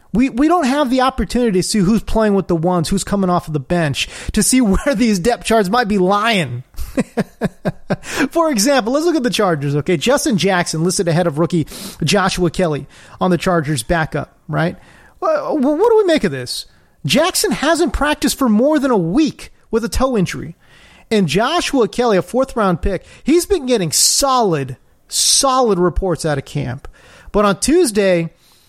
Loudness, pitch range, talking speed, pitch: -16 LUFS, 175-260 Hz, 180 wpm, 205 Hz